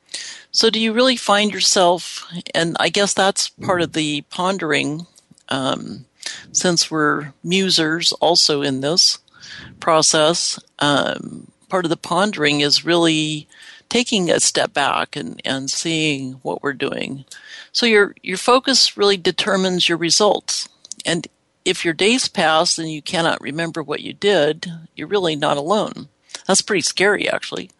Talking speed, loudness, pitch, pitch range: 145 wpm, -17 LUFS, 170 Hz, 155-200 Hz